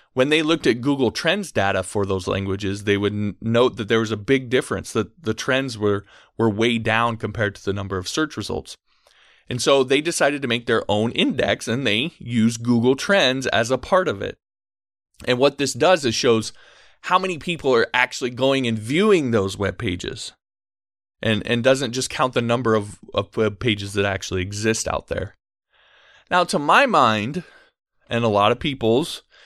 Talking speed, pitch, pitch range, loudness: 190 wpm, 115 Hz, 100-130 Hz, -21 LUFS